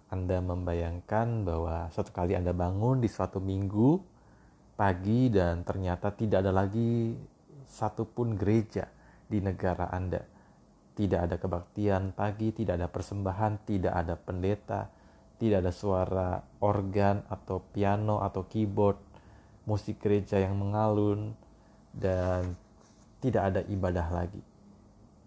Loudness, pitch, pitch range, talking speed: -31 LUFS, 100 Hz, 90-105 Hz, 115 wpm